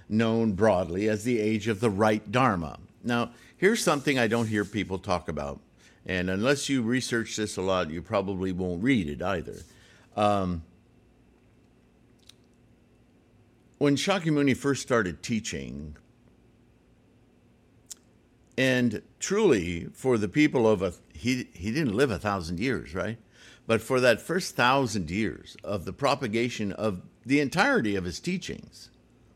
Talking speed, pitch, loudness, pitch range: 135 wpm, 110 Hz, -27 LUFS, 95-125 Hz